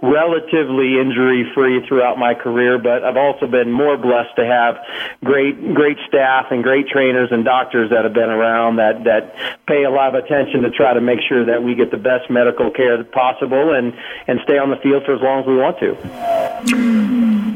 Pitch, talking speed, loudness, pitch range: 130 Hz, 200 wpm, -15 LUFS, 120-140 Hz